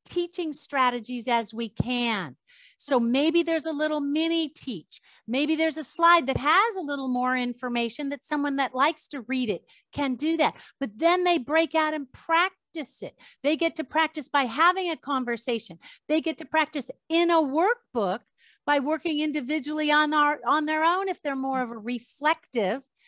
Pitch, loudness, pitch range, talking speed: 300 Hz, -26 LUFS, 260-320 Hz, 180 wpm